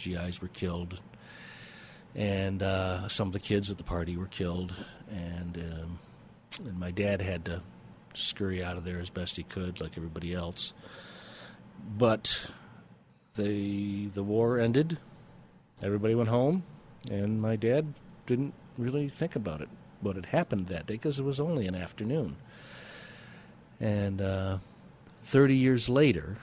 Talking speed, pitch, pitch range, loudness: 145 wpm, 100 Hz, 90-120 Hz, -31 LUFS